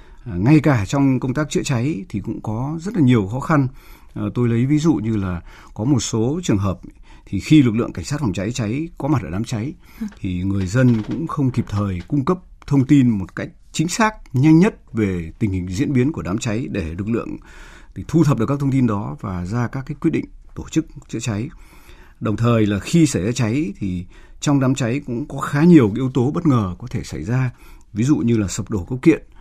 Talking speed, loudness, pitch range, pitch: 240 wpm, -19 LUFS, 105-145 Hz, 120 Hz